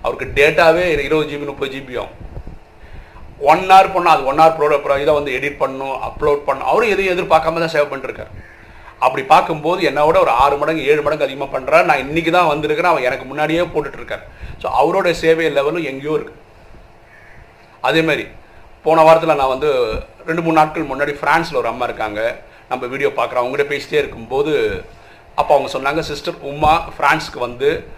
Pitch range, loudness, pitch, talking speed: 140-175 Hz, -16 LUFS, 155 Hz, 160 wpm